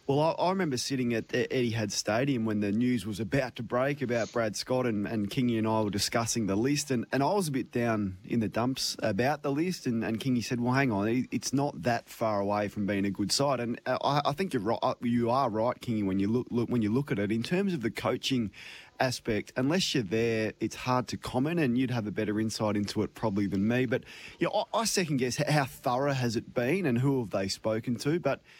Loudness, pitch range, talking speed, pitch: -30 LUFS, 110-135 Hz, 255 wpm, 120 Hz